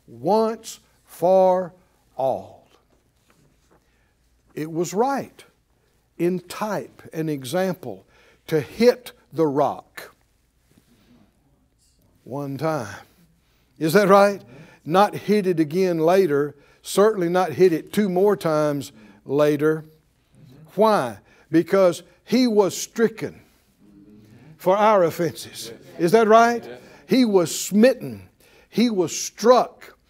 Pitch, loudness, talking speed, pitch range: 175 Hz, -21 LUFS, 100 wpm, 145-200 Hz